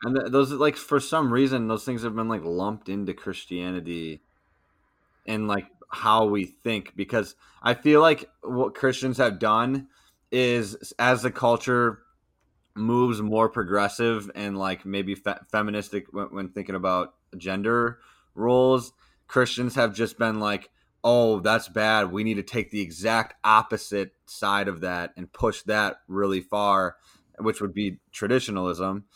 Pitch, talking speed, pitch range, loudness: 110 Hz, 150 wpm, 100-120 Hz, -25 LUFS